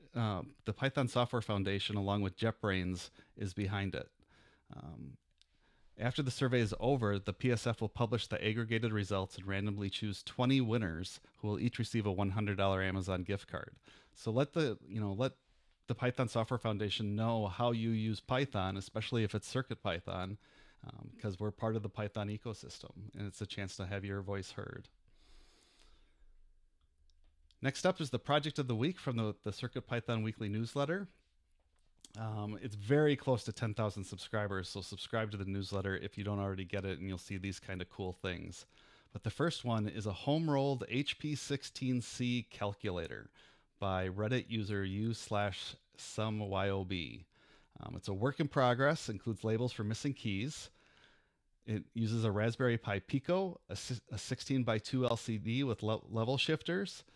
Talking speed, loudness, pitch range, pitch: 165 wpm, -37 LUFS, 100-125 Hz, 110 Hz